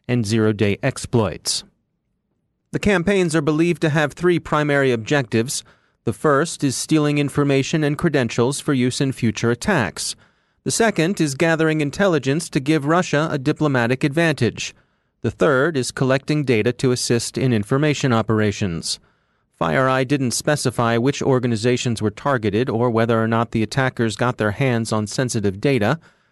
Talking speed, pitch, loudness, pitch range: 150 wpm, 135 Hz, -20 LUFS, 115-150 Hz